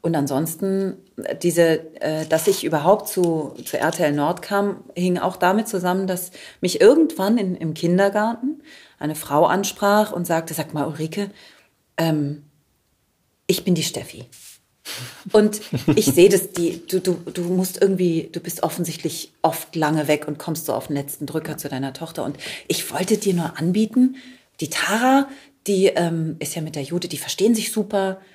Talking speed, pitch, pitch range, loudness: 165 wpm, 175 Hz, 155-200 Hz, -21 LUFS